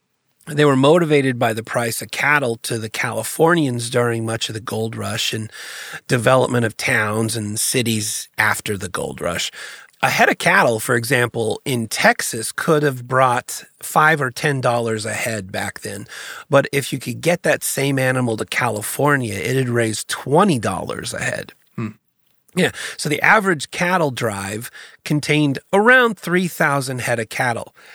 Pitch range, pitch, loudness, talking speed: 115-145 Hz, 125 Hz, -18 LUFS, 165 wpm